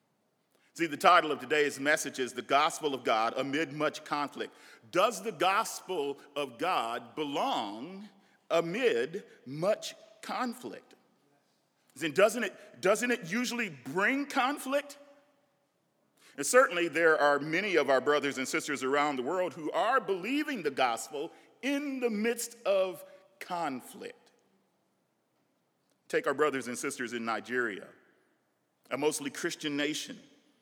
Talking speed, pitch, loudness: 125 wpm, 180 Hz, -30 LUFS